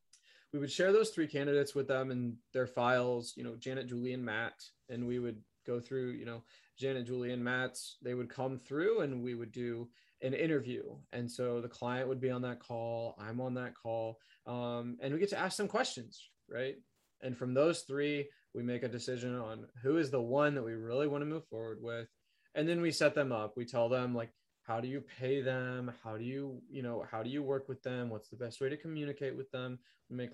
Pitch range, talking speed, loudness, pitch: 120-135 Hz, 230 wpm, -37 LUFS, 125 Hz